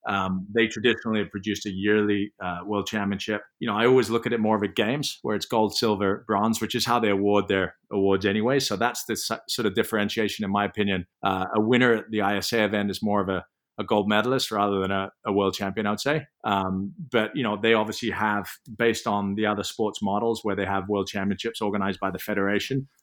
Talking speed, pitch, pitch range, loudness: 230 wpm, 105 Hz, 100-110 Hz, -25 LUFS